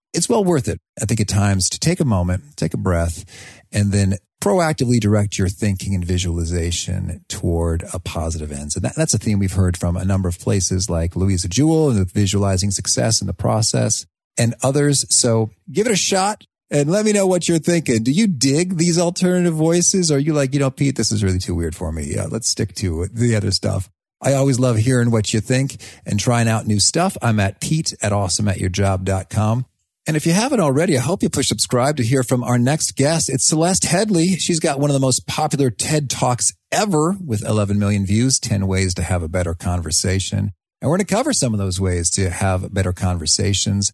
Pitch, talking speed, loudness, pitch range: 110 Hz, 220 wpm, -18 LUFS, 95-140 Hz